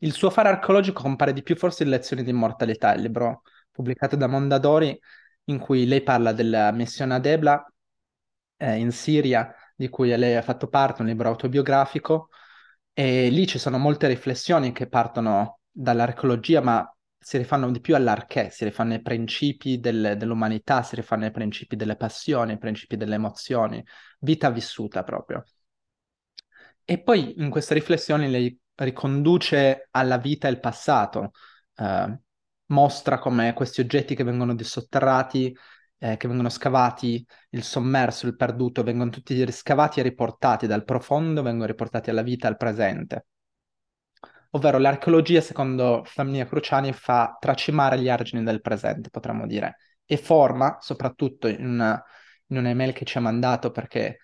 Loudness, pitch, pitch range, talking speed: -23 LUFS, 130 Hz, 120-140 Hz, 150 wpm